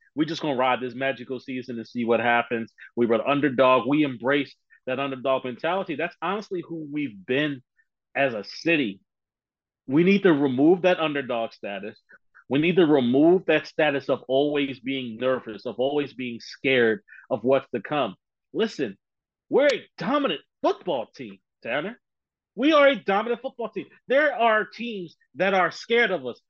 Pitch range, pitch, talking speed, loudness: 130-180 Hz, 140 Hz, 165 wpm, -24 LUFS